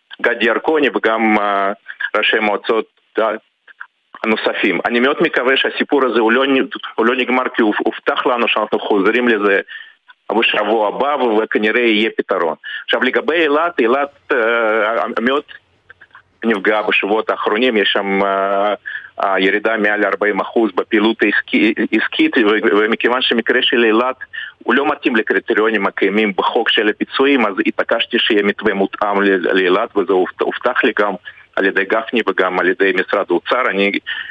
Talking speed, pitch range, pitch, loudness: 135 wpm, 100-125 Hz, 105 Hz, -15 LUFS